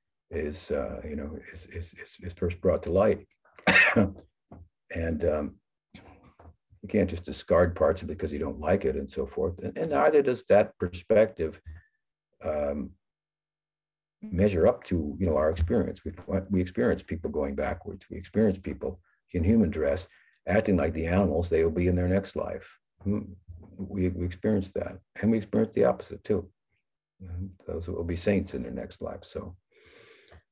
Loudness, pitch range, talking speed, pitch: -28 LUFS, 85-105 Hz, 170 wpm, 95 Hz